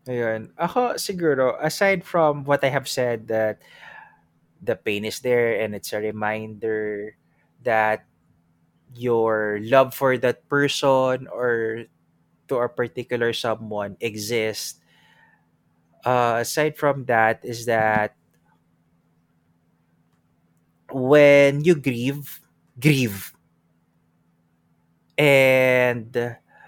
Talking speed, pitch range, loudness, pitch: 90 wpm, 85-130 Hz, -21 LUFS, 110 Hz